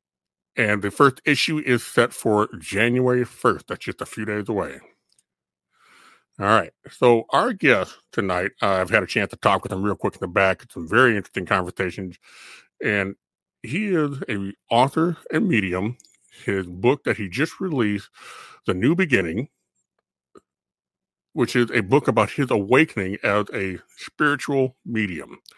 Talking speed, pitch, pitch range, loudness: 155 wpm, 110 Hz, 95-130 Hz, -22 LUFS